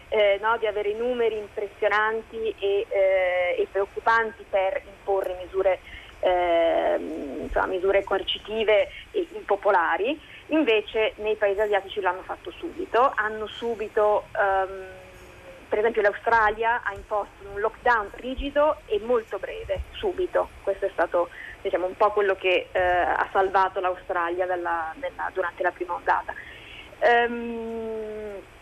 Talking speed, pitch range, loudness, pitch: 125 wpm, 190-230 Hz, -25 LUFS, 210 Hz